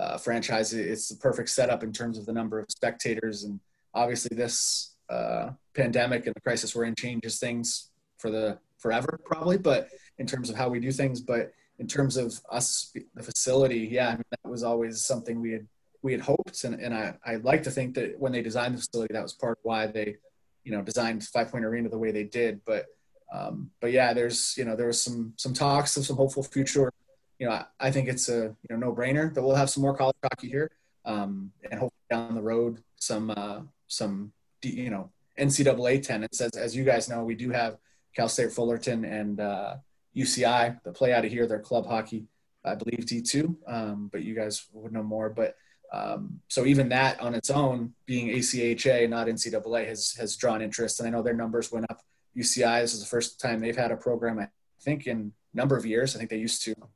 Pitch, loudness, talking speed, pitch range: 120 Hz, -29 LUFS, 220 wpm, 110-130 Hz